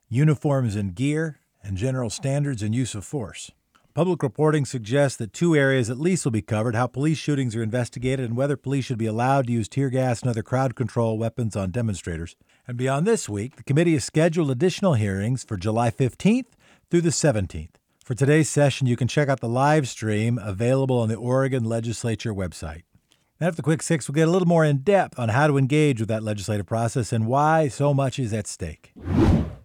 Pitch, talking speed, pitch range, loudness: 130 Hz, 205 wpm, 115-145 Hz, -23 LUFS